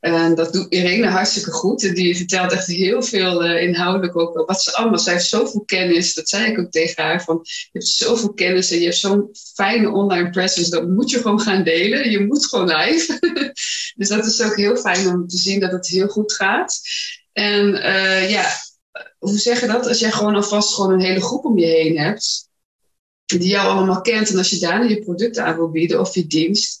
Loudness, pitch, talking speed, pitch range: -17 LUFS, 190 Hz, 220 wpm, 180-215 Hz